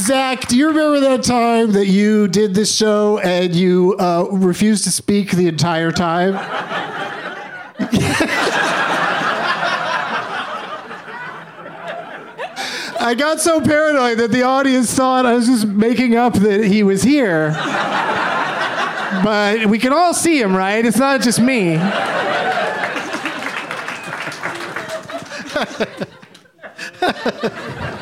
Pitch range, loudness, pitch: 195-255 Hz, -16 LUFS, 220 Hz